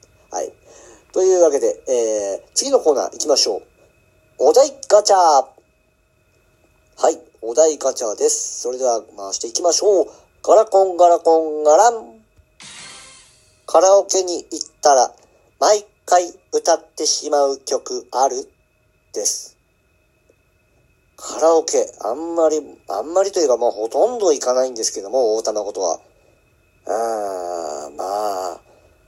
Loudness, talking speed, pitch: -18 LUFS, 260 characters per minute, 180 Hz